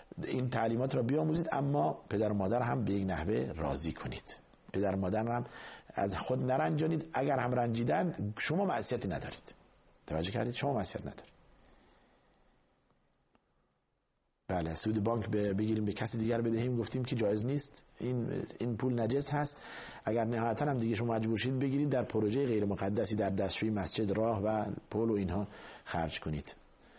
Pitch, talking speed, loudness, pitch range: 115 Hz, 155 wpm, -34 LUFS, 100-130 Hz